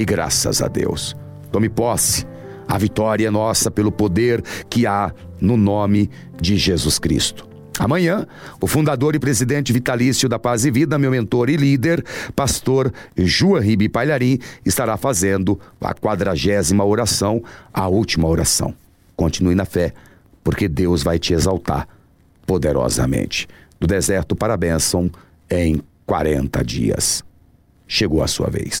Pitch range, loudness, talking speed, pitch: 90-120 Hz, -18 LUFS, 135 wpm, 105 Hz